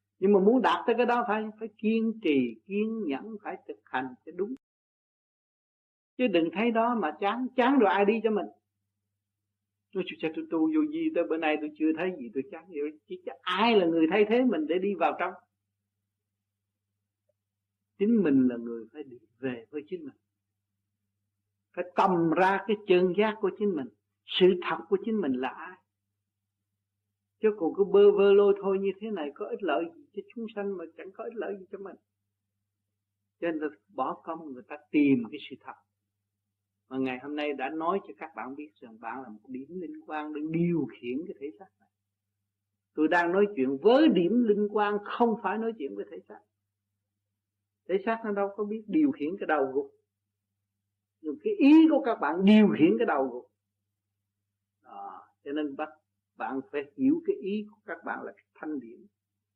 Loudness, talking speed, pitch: -27 LUFS, 200 wpm, 155 Hz